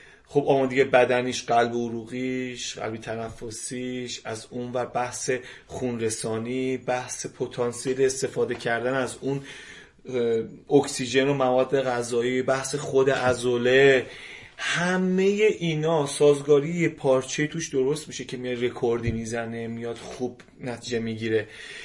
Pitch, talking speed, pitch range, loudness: 125 Hz, 115 wpm, 120-135 Hz, -25 LUFS